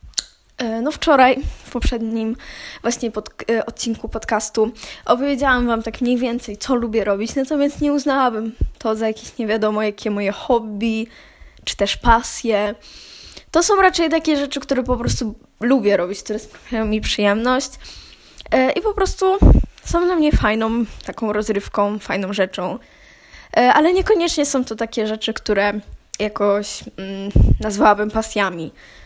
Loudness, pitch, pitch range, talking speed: -19 LUFS, 225 Hz, 210-265 Hz, 140 wpm